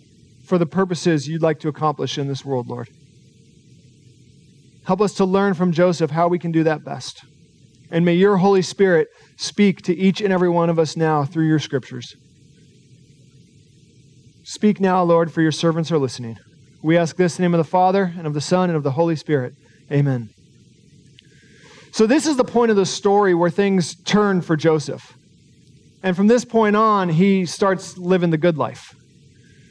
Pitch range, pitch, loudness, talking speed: 140-185 Hz, 160 Hz, -19 LUFS, 185 wpm